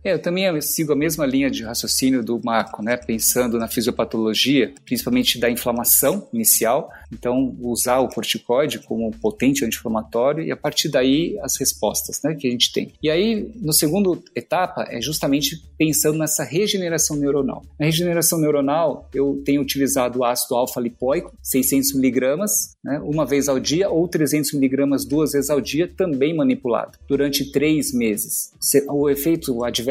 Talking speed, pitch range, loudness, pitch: 155 wpm, 125-160 Hz, -20 LUFS, 140 Hz